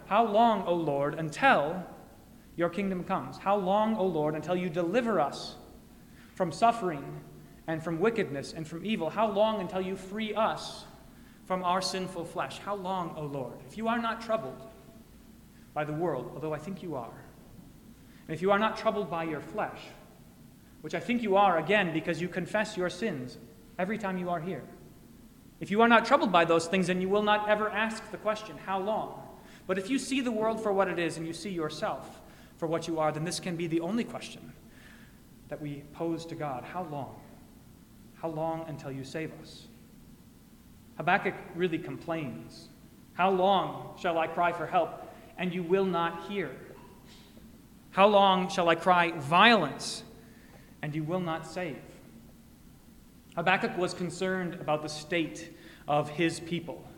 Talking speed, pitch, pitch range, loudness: 175 wpm, 180 Hz, 160-200 Hz, -30 LUFS